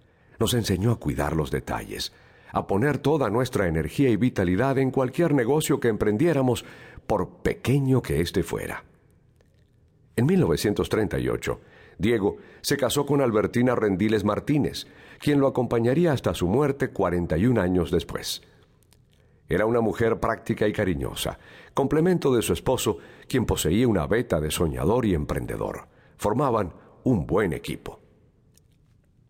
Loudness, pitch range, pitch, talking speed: -25 LUFS, 100-135 Hz, 120 Hz, 130 wpm